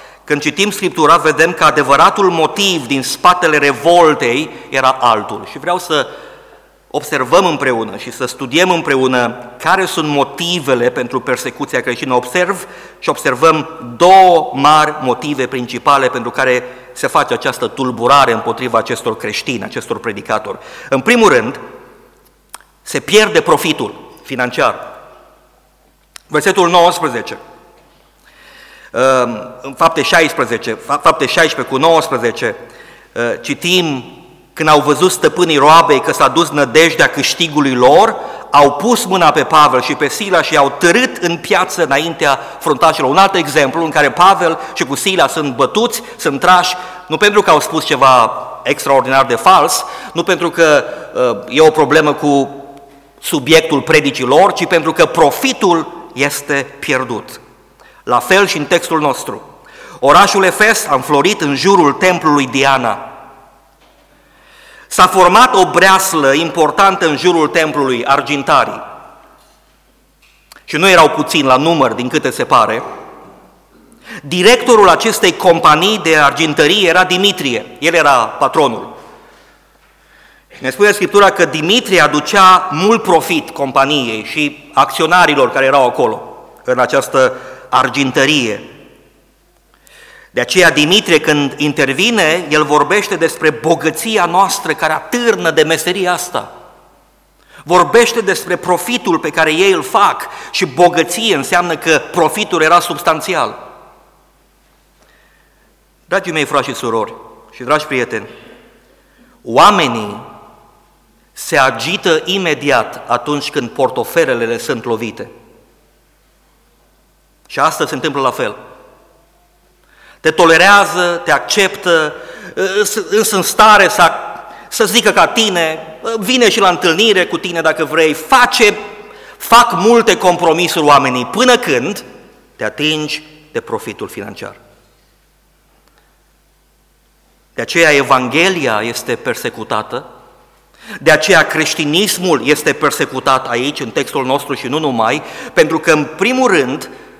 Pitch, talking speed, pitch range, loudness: 165 Hz, 120 wpm, 145-195 Hz, -11 LUFS